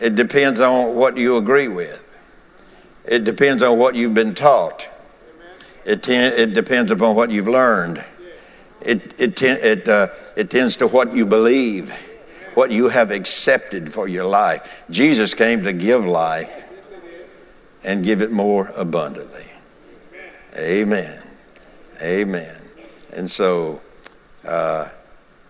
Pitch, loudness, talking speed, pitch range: 115 Hz, -17 LUFS, 130 wpm, 110-125 Hz